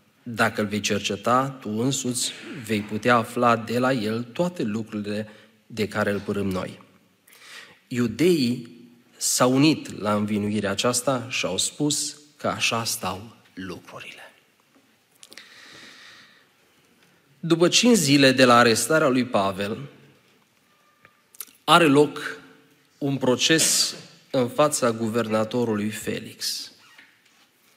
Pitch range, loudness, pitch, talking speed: 110-140 Hz, -22 LUFS, 120 Hz, 105 wpm